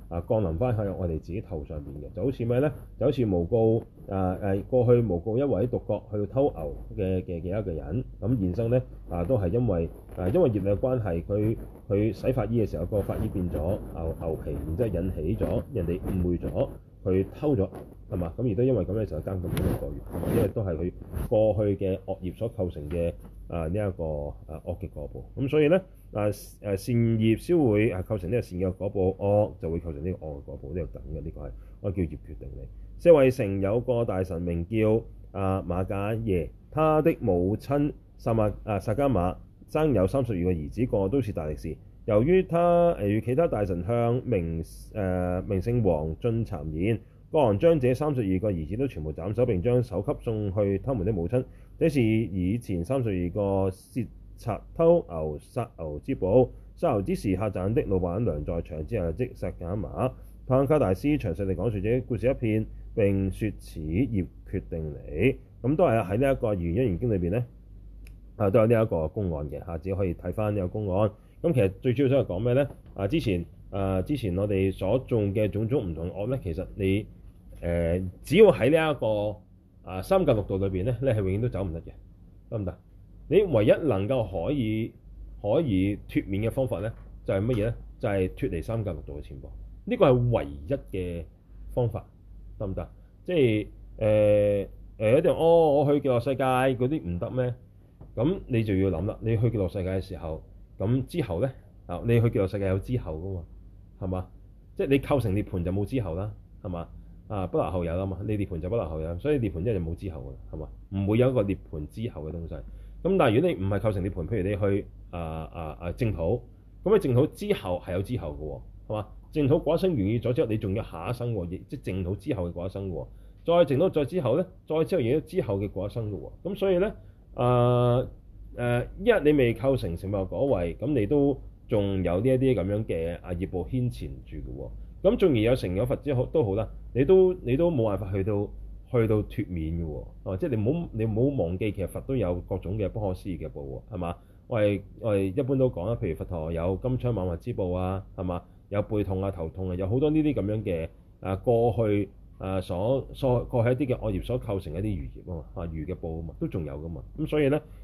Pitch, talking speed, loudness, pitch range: 100 Hz, 310 characters per minute, -27 LUFS, 90-120 Hz